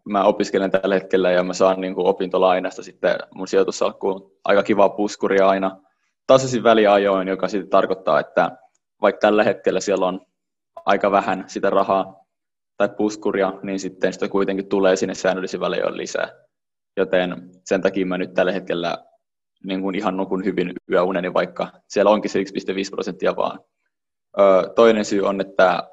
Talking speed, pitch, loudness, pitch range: 160 wpm, 95 Hz, -20 LUFS, 95-100 Hz